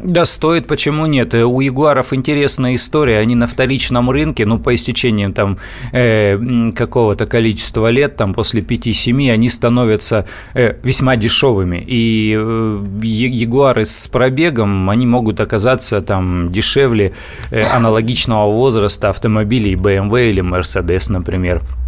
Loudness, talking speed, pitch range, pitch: -13 LUFS, 125 wpm, 105-125 Hz, 115 Hz